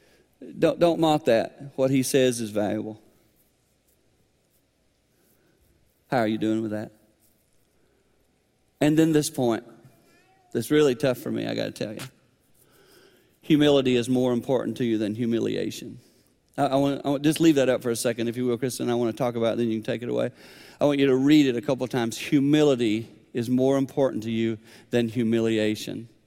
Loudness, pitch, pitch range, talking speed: -24 LUFS, 120 Hz, 110-135 Hz, 185 wpm